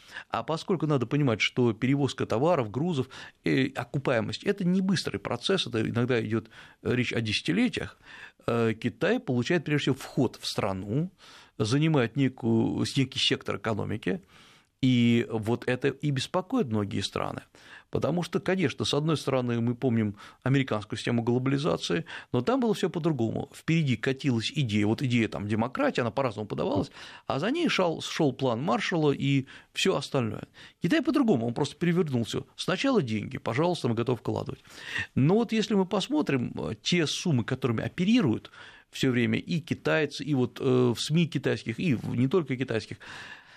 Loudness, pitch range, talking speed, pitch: -28 LUFS, 120-160 Hz, 145 wpm, 135 Hz